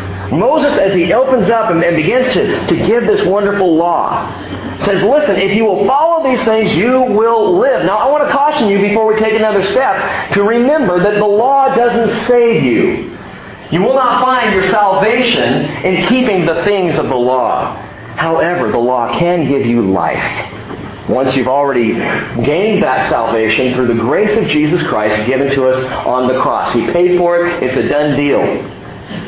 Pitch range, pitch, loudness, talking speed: 140-230 Hz, 190 Hz, -12 LUFS, 180 wpm